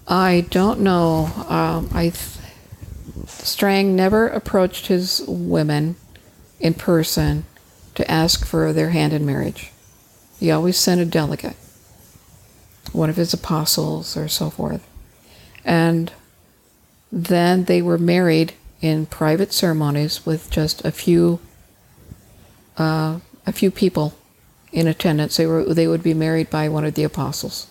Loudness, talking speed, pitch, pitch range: -19 LUFS, 130 wpm, 160 Hz, 135-175 Hz